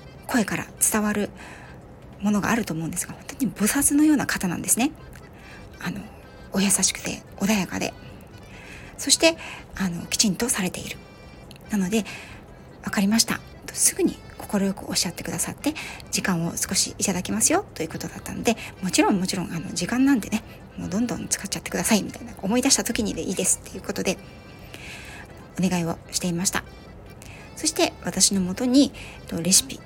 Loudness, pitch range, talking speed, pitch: -23 LUFS, 185-235 Hz, 370 characters per minute, 205 Hz